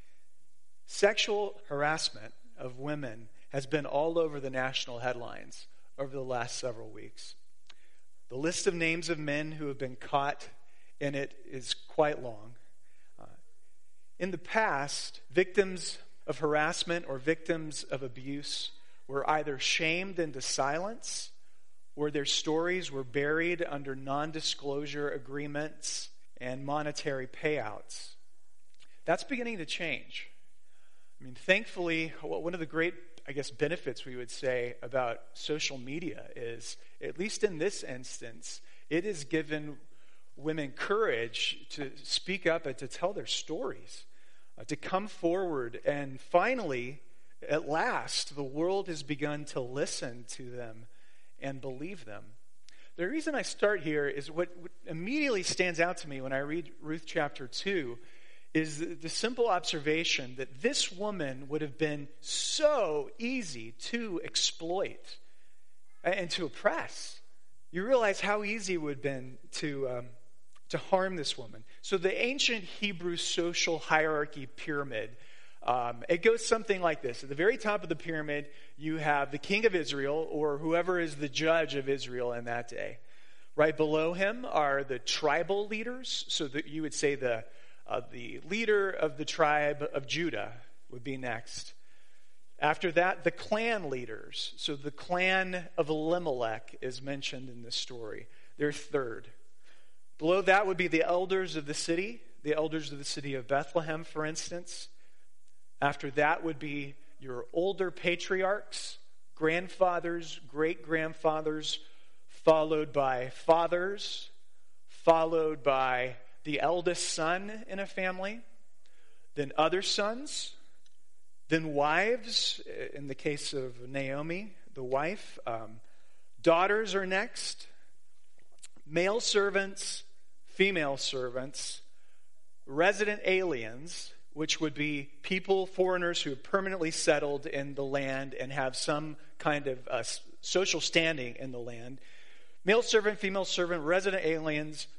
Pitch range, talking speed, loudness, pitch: 140-180 Hz, 140 wpm, -32 LUFS, 155 Hz